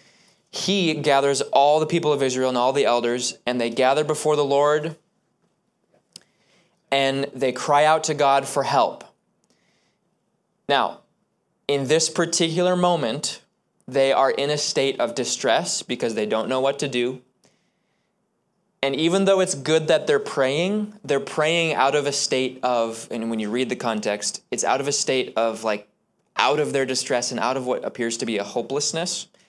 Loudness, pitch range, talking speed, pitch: -22 LUFS, 125-160 Hz, 175 wpm, 140 Hz